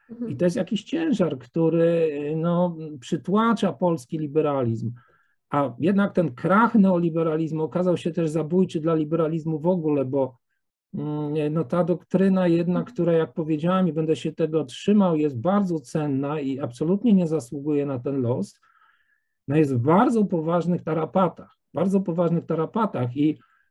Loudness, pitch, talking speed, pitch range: -23 LUFS, 165 Hz, 140 wpm, 155-185 Hz